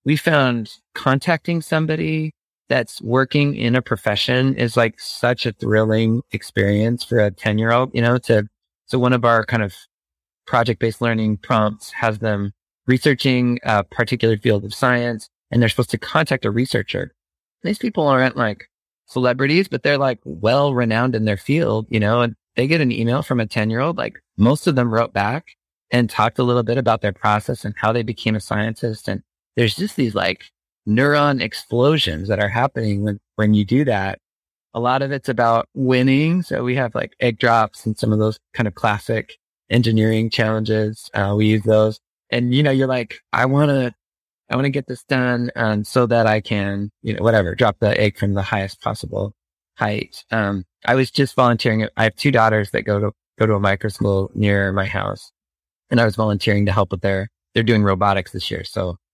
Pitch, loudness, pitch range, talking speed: 115 Hz, -19 LUFS, 105-125 Hz, 200 wpm